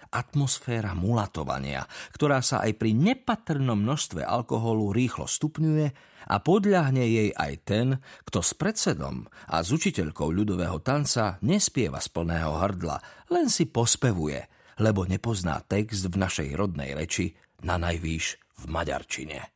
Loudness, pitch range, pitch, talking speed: -26 LUFS, 85-135 Hz, 110 Hz, 130 wpm